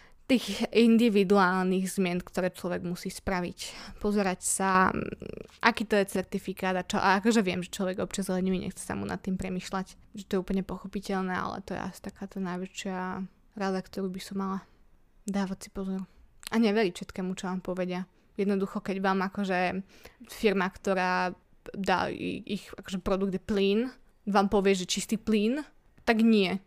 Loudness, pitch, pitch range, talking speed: -29 LUFS, 195 Hz, 185-205 Hz, 160 wpm